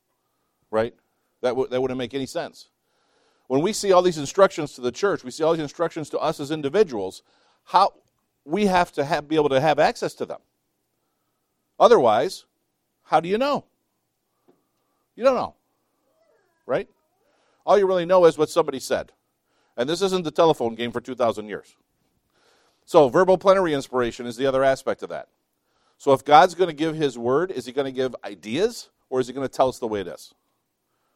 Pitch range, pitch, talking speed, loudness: 130-175 Hz, 145 Hz, 190 wpm, -22 LUFS